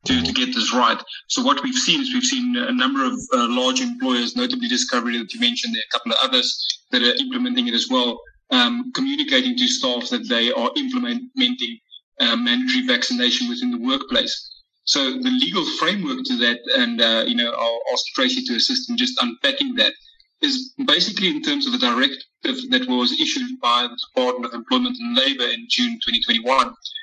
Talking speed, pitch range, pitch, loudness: 195 wpm, 245-265 Hz, 255 Hz, -19 LUFS